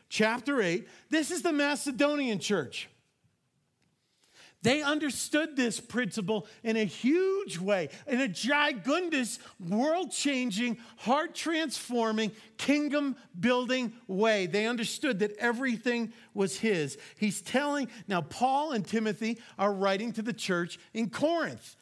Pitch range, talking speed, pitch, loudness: 210-285 Hz, 120 wpm, 235 Hz, -30 LUFS